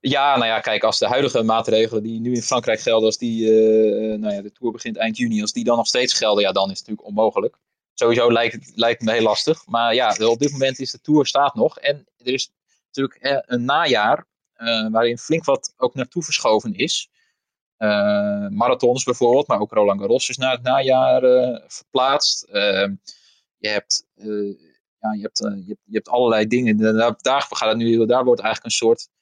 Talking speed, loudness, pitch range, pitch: 190 wpm, -19 LUFS, 110-135 Hz, 120 Hz